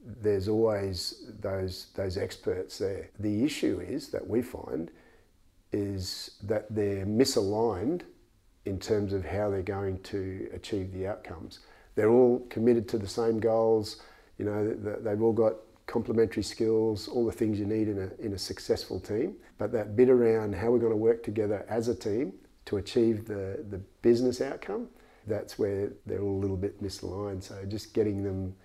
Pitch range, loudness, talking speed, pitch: 100-115 Hz, -30 LUFS, 170 wpm, 105 Hz